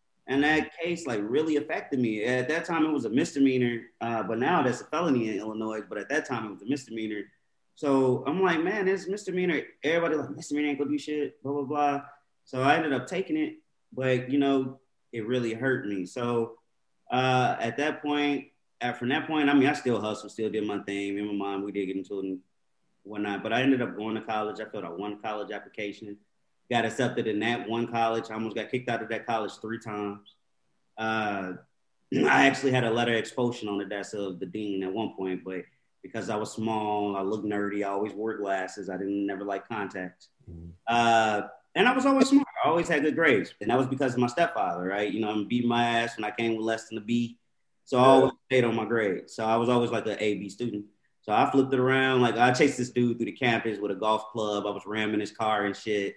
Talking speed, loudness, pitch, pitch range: 240 wpm, -28 LUFS, 115 Hz, 105-135 Hz